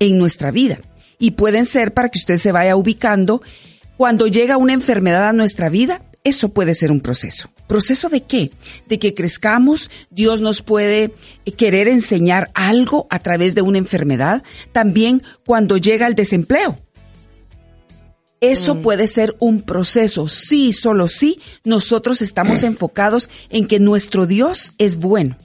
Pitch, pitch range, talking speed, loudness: 215 Hz, 180-235 Hz, 150 wpm, -14 LUFS